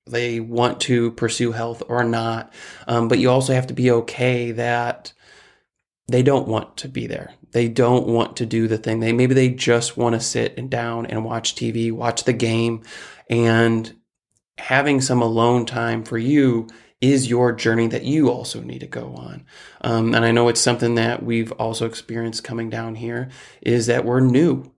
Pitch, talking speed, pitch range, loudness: 115 Hz, 190 wpm, 115-125 Hz, -20 LUFS